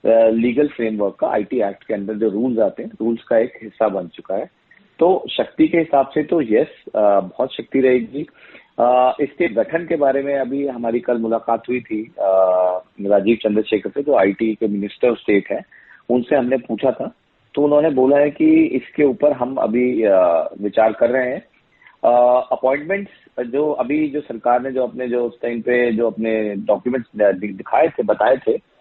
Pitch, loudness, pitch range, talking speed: 120 Hz, -18 LUFS, 110-135 Hz, 185 wpm